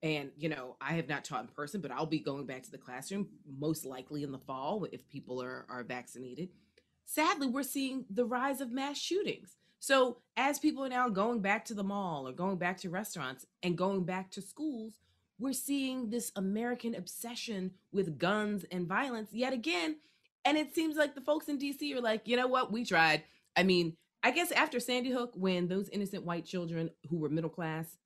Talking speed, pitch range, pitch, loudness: 205 wpm, 165-250 Hz, 195 Hz, -35 LUFS